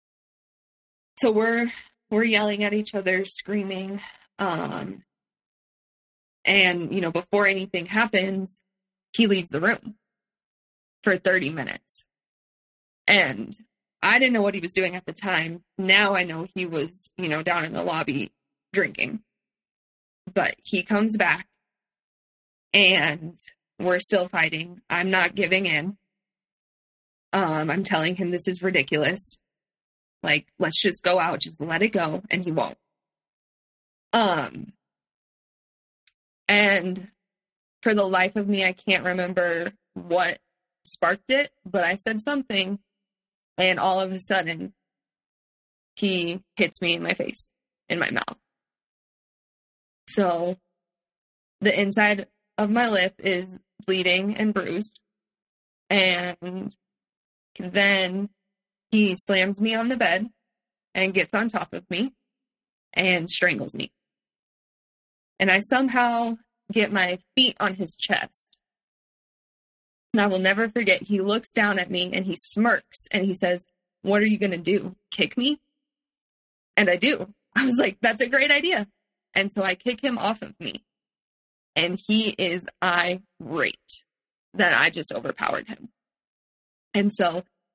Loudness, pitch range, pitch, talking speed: -23 LUFS, 180-215 Hz, 195 Hz, 135 wpm